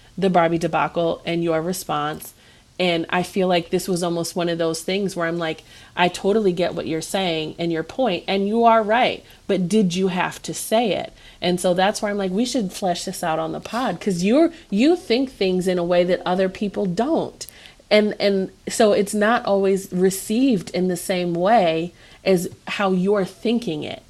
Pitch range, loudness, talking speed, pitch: 170-205 Hz, -21 LUFS, 205 wpm, 185 Hz